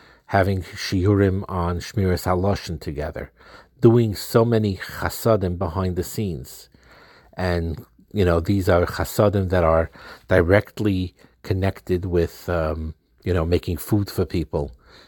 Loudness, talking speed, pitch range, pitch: -22 LUFS, 125 wpm, 85-100 Hz, 95 Hz